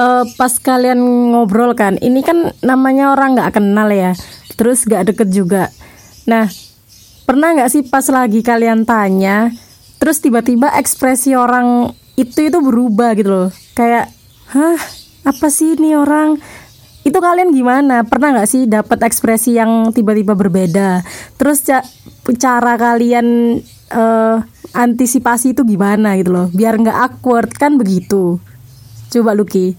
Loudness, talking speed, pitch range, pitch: -12 LUFS, 135 wpm, 215-265 Hz, 235 Hz